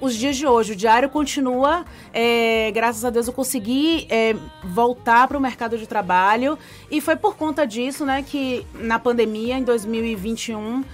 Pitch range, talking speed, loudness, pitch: 225-275 Hz, 170 wpm, -20 LUFS, 245 Hz